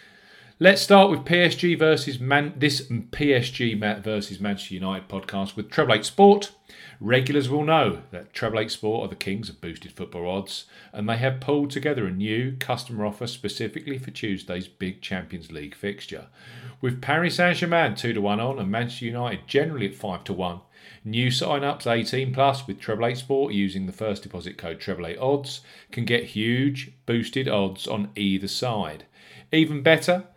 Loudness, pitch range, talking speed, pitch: -24 LUFS, 100-140 Hz, 160 wpm, 120 Hz